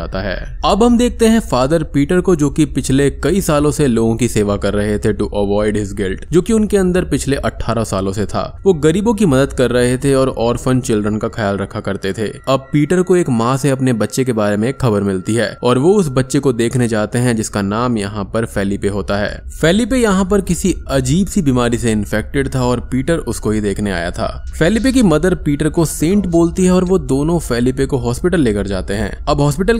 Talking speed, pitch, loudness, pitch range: 230 wpm, 130 Hz, -15 LUFS, 105-165 Hz